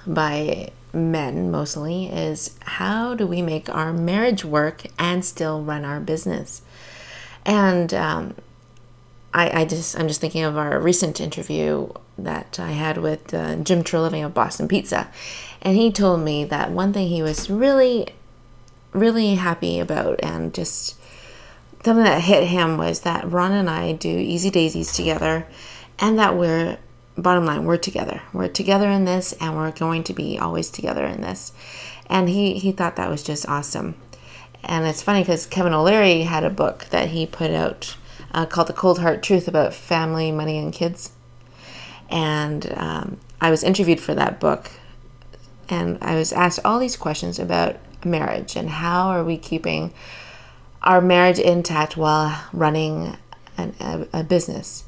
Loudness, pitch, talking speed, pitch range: -21 LUFS, 160 Hz, 165 wpm, 150-180 Hz